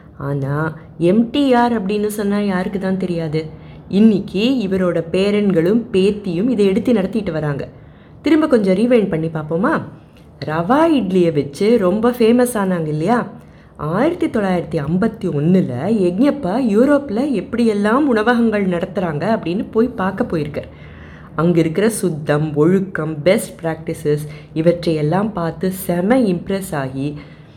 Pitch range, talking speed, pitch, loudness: 160-225 Hz, 115 wpm, 190 Hz, -17 LUFS